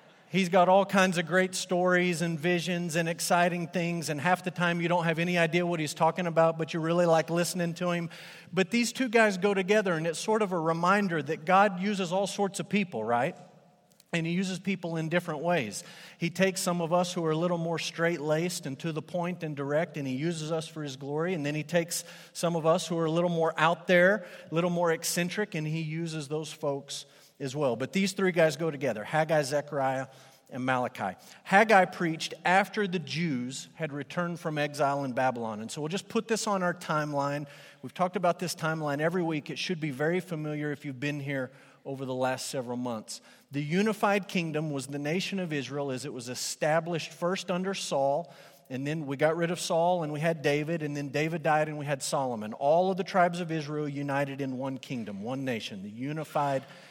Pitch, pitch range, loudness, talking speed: 165 Hz, 145-180 Hz, -29 LUFS, 220 wpm